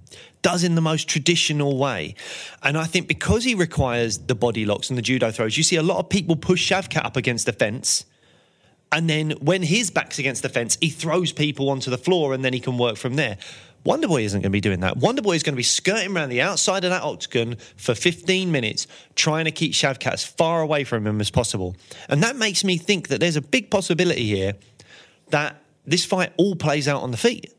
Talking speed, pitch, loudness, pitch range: 230 wpm, 150 Hz, -21 LUFS, 125-175 Hz